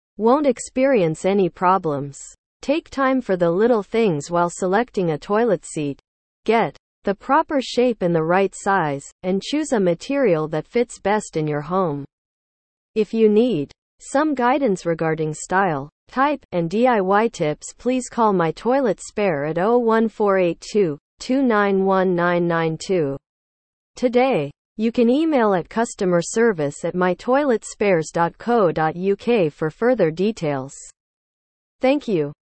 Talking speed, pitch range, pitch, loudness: 120 wpm, 165-240 Hz, 195 Hz, -20 LUFS